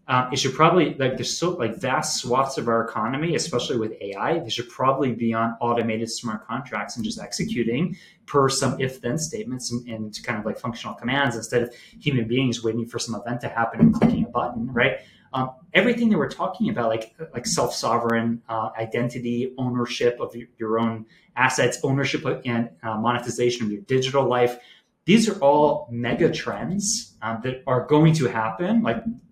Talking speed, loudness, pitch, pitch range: 190 wpm, -23 LUFS, 125 Hz, 115-150 Hz